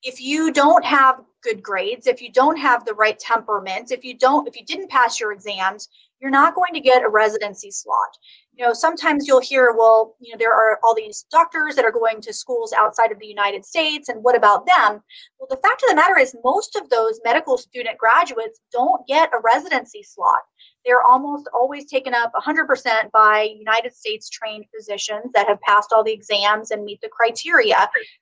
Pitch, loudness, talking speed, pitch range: 245 Hz, -18 LUFS, 205 wpm, 220-310 Hz